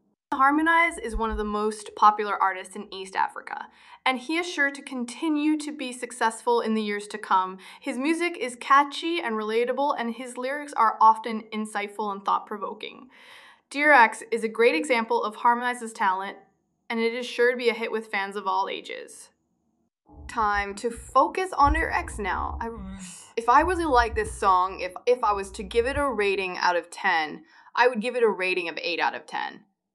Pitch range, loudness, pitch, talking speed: 210-280 Hz, -25 LUFS, 235 Hz, 190 wpm